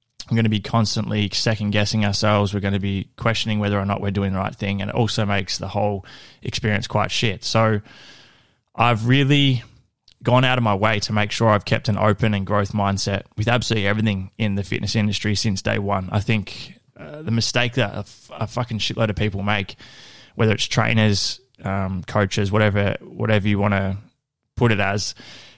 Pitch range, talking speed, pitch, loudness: 100-115 Hz, 200 wpm, 105 Hz, -21 LUFS